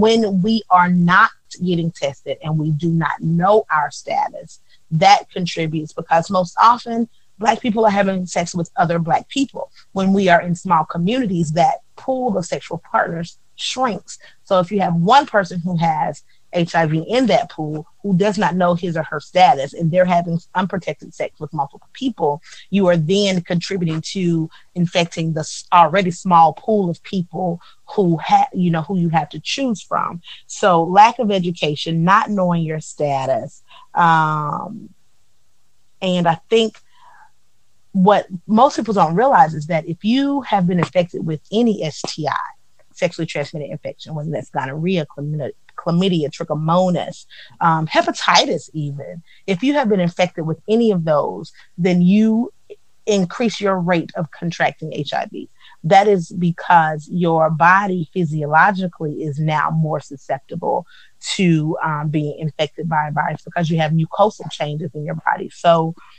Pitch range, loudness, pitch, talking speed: 160-200 Hz, -18 LUFS, 175 Hz, 155 wpm